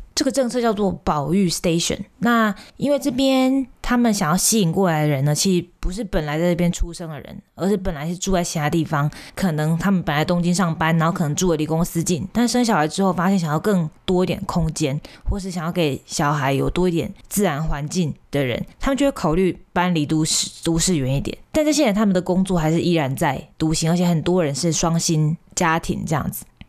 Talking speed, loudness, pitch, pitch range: 340 characters per minute, -20 LUFS, 175 Hz, 160-195 Hz